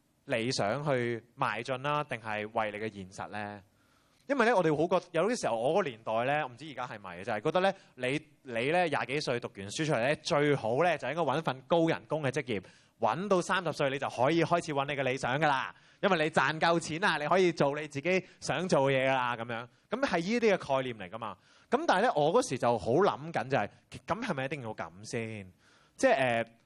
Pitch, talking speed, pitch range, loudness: 140 Hz, 320 characters per minute, 115-160 Hz, -31 LUFS